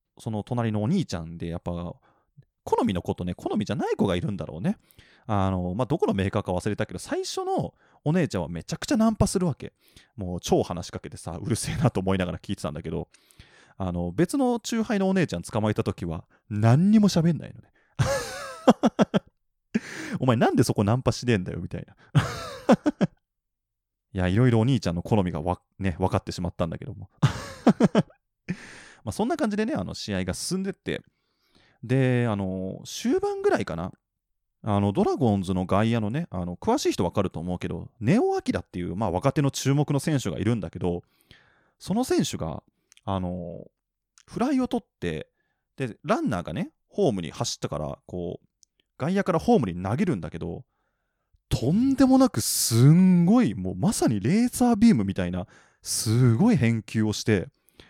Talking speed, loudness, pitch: 360 characters per minute, -25 LUFS, 115 Hz